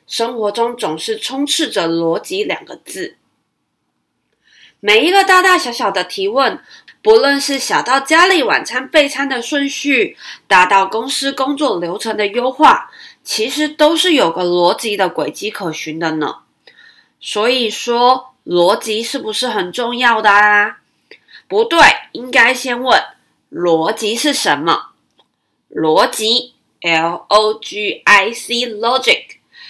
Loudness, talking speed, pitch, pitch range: -14 LUFS, 220 characters per minute, 245 Hz, 210-305 Hz